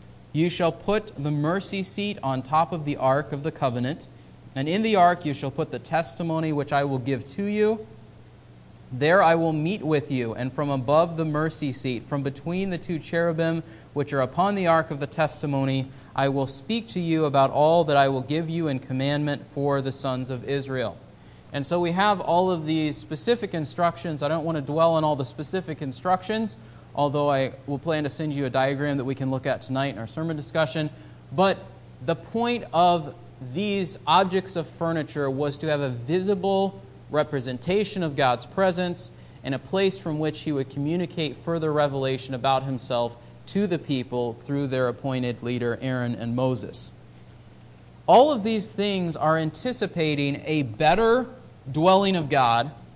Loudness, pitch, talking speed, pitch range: -25 LUFS, 150 Hz, 180 wpm, 135-170 Hz